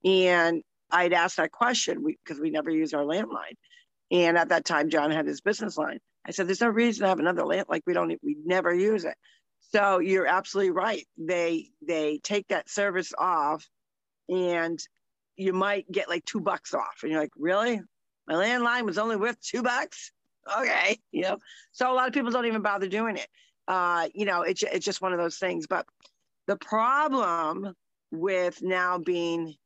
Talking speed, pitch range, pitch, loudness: 195 wpm, 170-220 Hz, 190 Hz, -27 LUFS